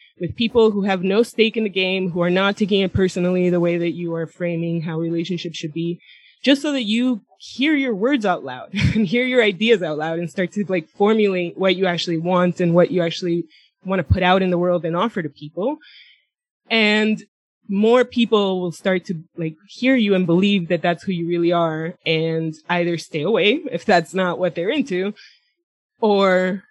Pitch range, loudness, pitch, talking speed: 170-215 Hz, -19 LUFS, 185 Hz, 205 wpm